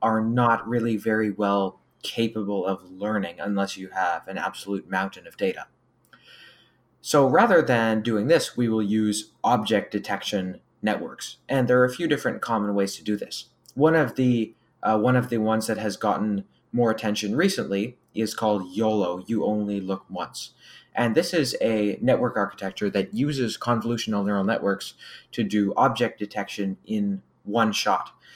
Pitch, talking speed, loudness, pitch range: 110 Hz, 165 wpm, -25 LUFS, 100-115 Hz